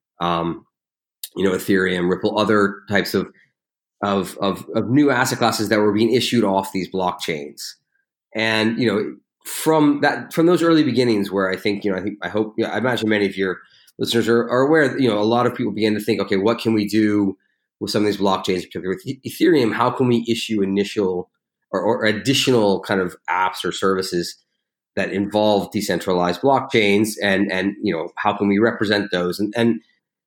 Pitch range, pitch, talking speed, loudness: 95-115 Hz, 105 Hz, 195 wpm, -19 LUFS